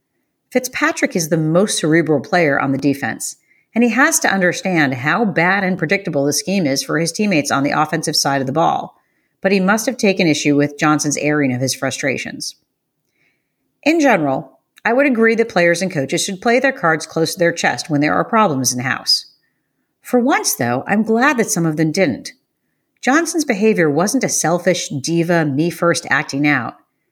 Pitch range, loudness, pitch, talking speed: 145-220 Hz, -16 LUFS, 170 Hz, 195 wpm